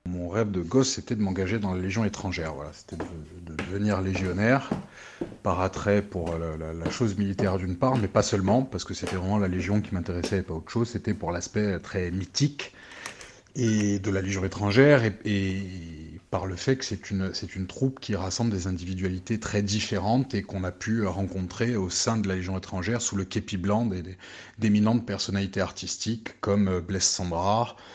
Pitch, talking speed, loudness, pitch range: 95 Hz, 200 wpm, -27 LUFS, 90-105 Hz